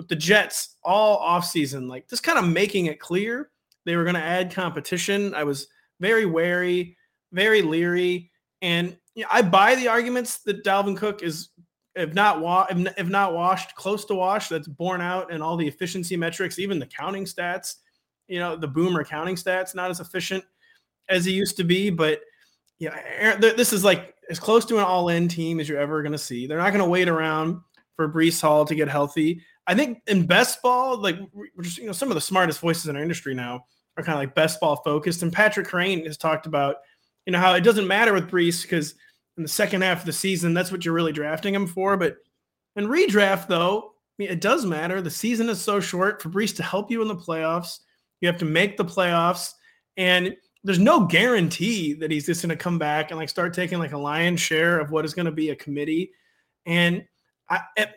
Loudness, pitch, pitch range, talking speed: -23 LUFS, 180 Hz, 165-200 Hz, 220 wpm